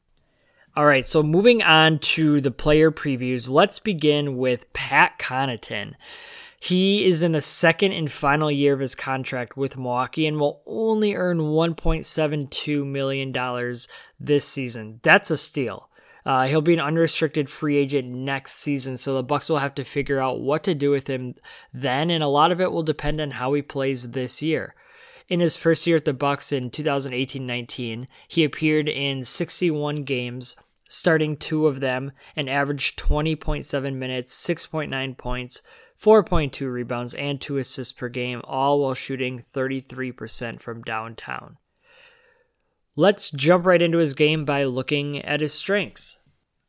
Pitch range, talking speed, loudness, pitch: 130-160 Hz, 155 wpm, -22 LUFS, 145 Hz